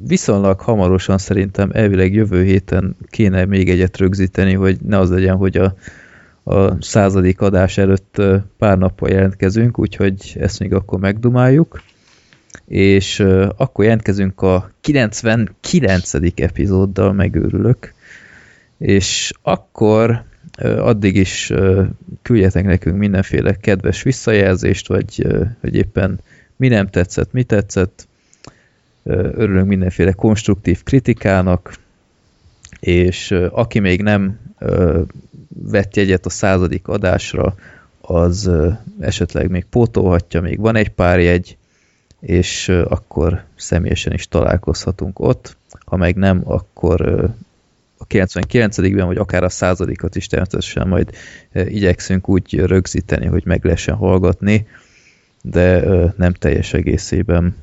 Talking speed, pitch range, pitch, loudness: 120 wpm, 90-105 Hz, 95 Hz, -15 LUFS